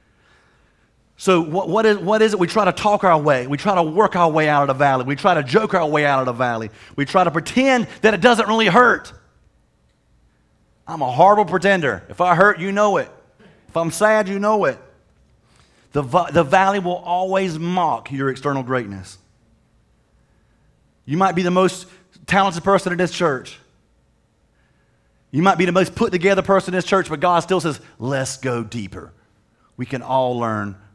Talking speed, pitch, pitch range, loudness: 185 wpm, 175 Hz, 135-195 Hz, -18 LUFS